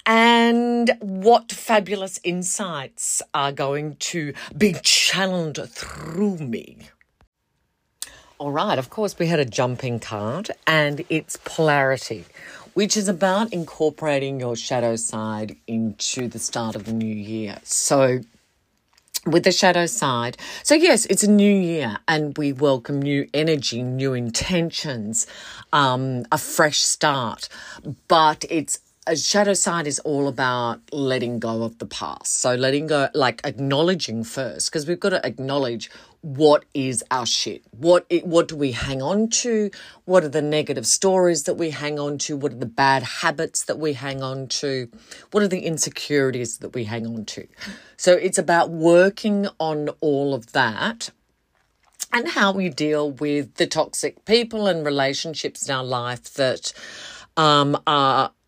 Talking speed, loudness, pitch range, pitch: 150 wpm, -21 LUFS, 130-175 Hz, 150 Hz